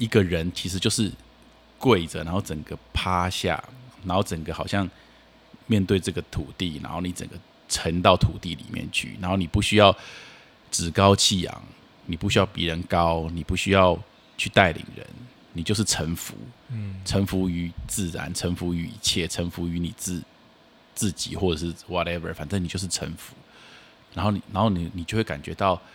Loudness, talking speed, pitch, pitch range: -25 LUFS, 270 characters per minute, 90 Hz, 85-100 Hz